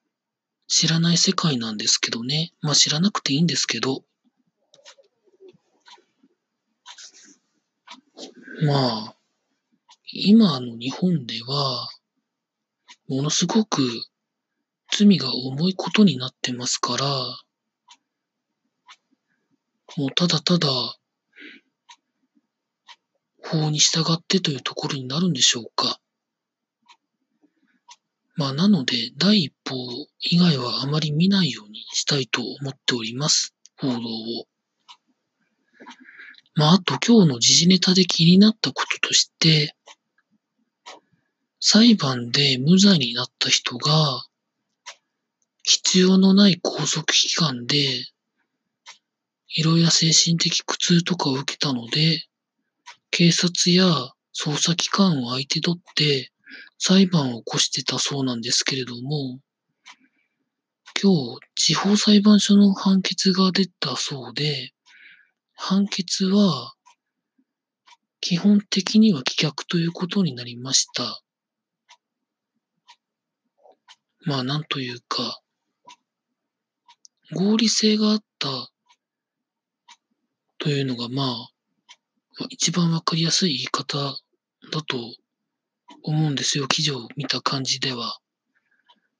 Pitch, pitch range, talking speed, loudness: 170 Hz, 135-215 Hz, 195 characters per minute, -20 LUFS